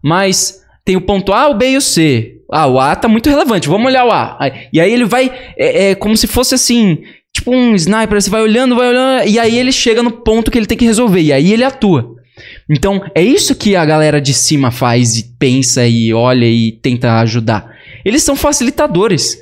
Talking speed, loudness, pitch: 220 wpm, -11 LUFS, 205 Hz